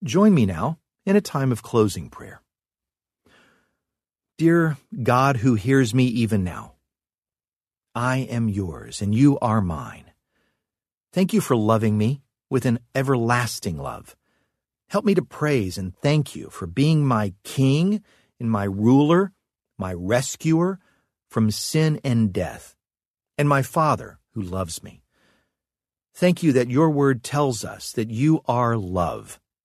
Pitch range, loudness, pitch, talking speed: 110-150 Hz, -22 LUFS, 125 Hz, 140 wpm